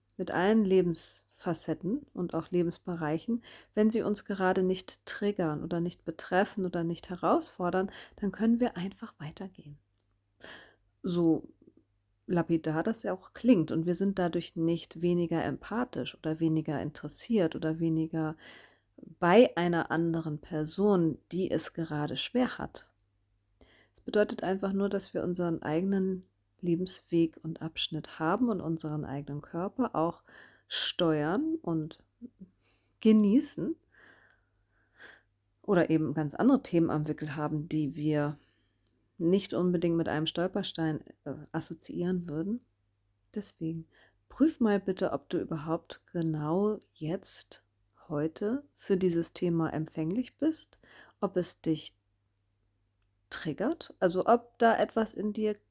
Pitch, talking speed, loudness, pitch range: 170 Hz, 120 wpm, -31 LUFS, 150-195 Hz